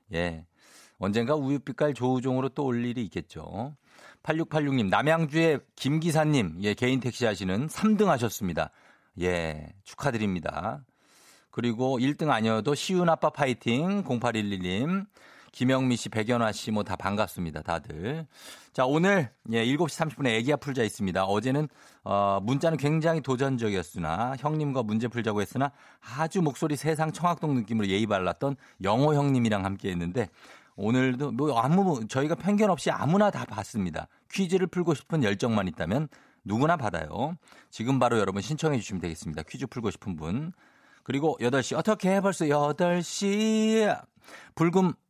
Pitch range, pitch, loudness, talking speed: 110-160 Hz, 130 Hz, -28 LUFS, 310 characters per minute